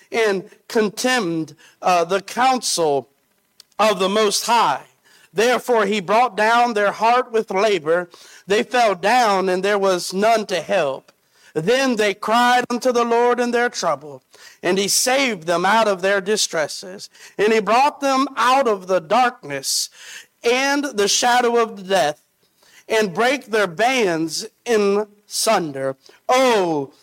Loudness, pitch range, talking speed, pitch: -18 LUFS, 190-240 Hz, 140 wpm, 215 Hz